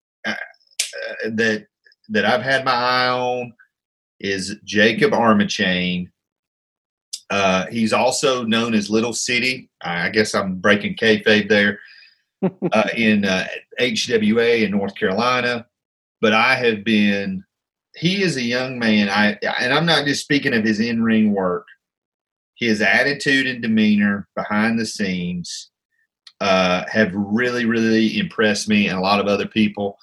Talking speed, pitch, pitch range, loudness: 140 wpm, 110 Hz, 105-125 Hz, -18 LUFS